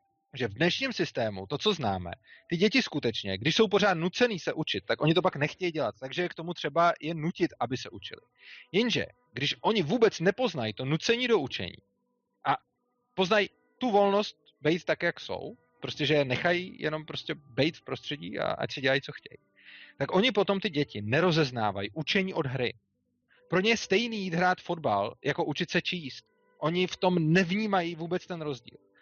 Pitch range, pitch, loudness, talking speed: 145-195 Hz, 170 Hz, -29 LUFS, 185 wpm